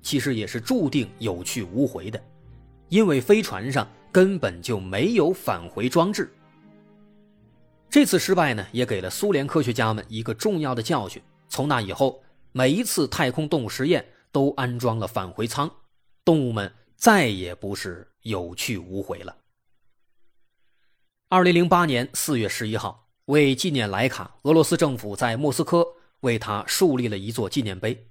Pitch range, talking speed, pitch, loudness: 110-165 Hz, 240 characters per minute, 130 Hz, -23 LUFS